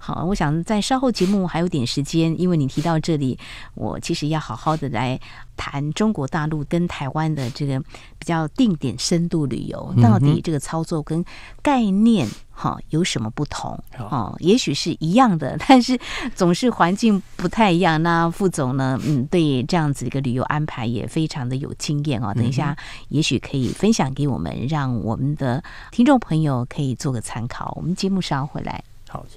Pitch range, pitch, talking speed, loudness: 130-175 Hz, 155 Hz, 280 characters per minute, -21 LUFS